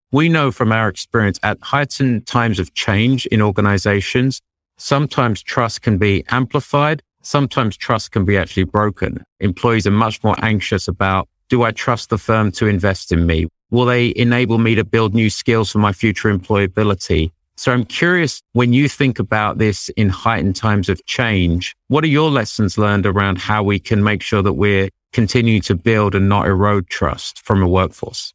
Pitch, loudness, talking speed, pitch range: 105 Hz, -16 LUFS, 180 wpm, 100-120 Hz